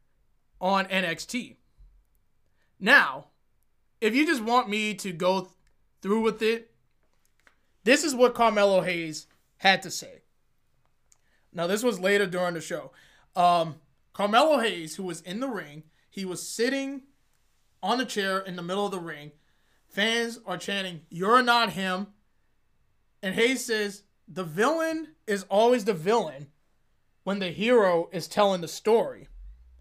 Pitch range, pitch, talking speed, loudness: 165-225 Hz, 190 Hz, 145 wpm, -26 LUFS